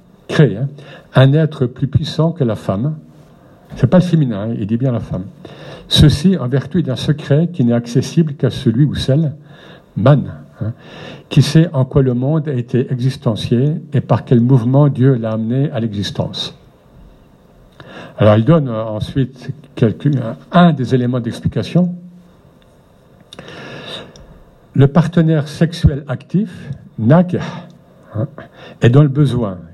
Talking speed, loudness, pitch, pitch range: 145 wpm, -15 LUFS, 140 Hz, 125-155 Hz